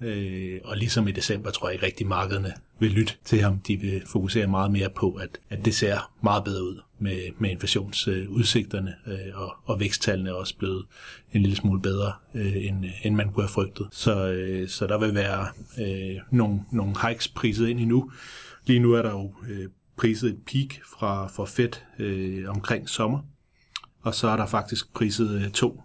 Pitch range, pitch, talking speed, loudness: 95-115 Hz, 105 Hz, 195 wpm, -26 LUFS